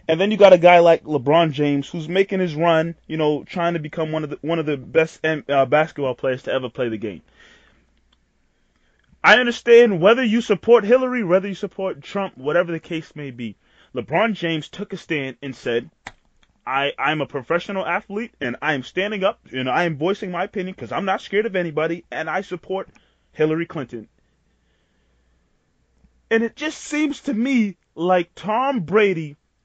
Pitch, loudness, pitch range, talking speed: 165 Hz, -20 LUFS, 140-195 Hz, 180 wpm